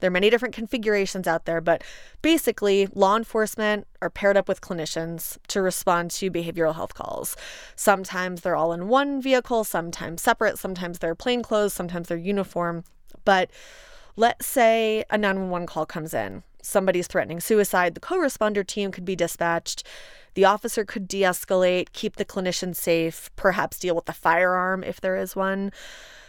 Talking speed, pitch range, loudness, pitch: 160 wpm, 170-215 Hz, -24 LUFS, 190 Hz